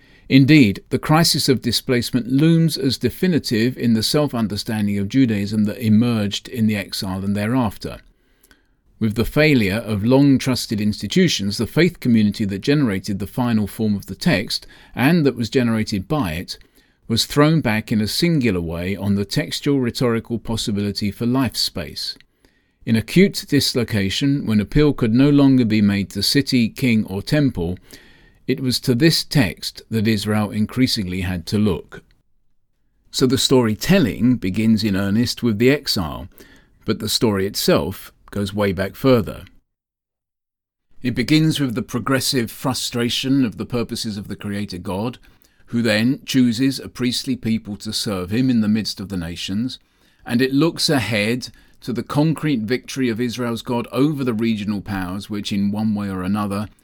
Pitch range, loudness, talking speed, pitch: 105-130 Hz, -19 LUFS, 160 wpm, 115 Hz